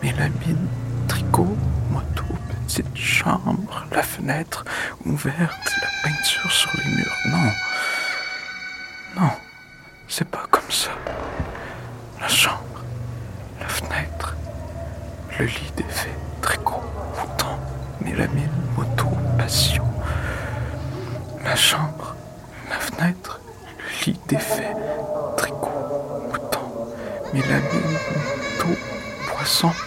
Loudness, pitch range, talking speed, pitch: -23 LUFS, 115-160 Hz, 90 wpm, 125 Hz